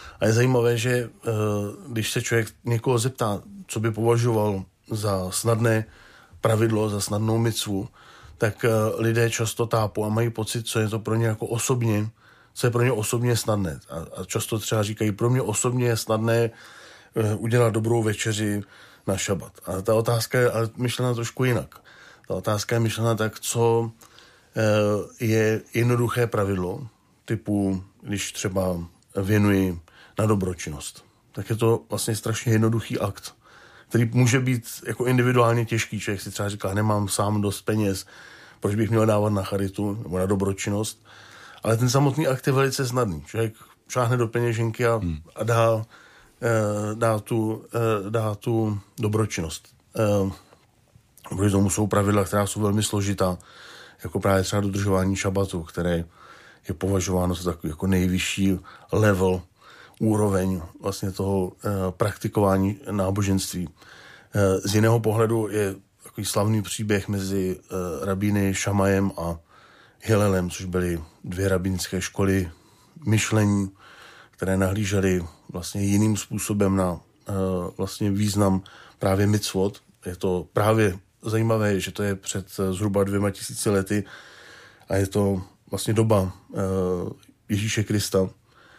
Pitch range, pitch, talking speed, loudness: 95-115 Hz, 105 Hz, 135 wpm, -24 LUFS